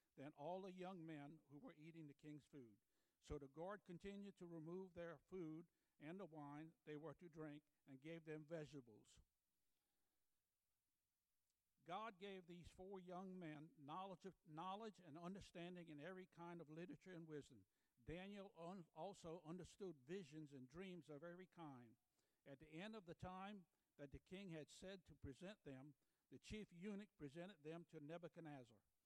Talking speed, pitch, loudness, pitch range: 165 wpm, 165 Hz, -59 LUFS, 145-185 Hz